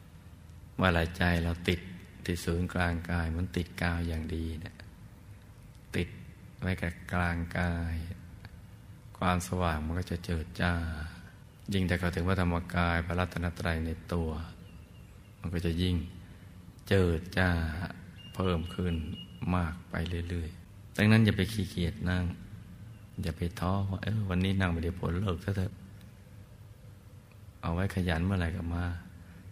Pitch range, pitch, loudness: 85-100 Hz, 90 Hz, -32 LUFS